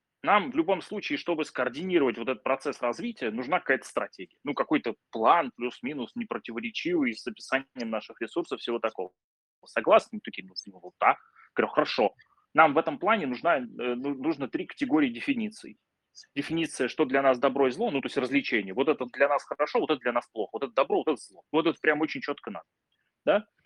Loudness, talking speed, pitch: -28 LUFS, 195 wpm, 150 Hz